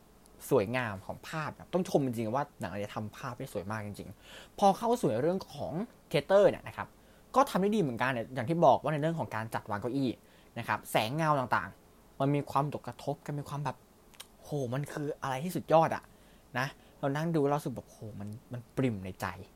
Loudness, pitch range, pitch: -32 LUFS, 110-155 Hz, 135 Hz